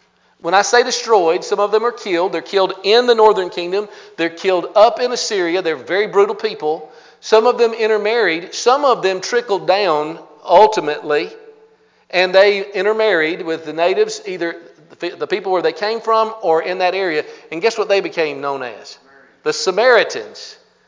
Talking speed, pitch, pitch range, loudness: 170 wpm, 200 Hz, 170-235 Hz, -16 LUFS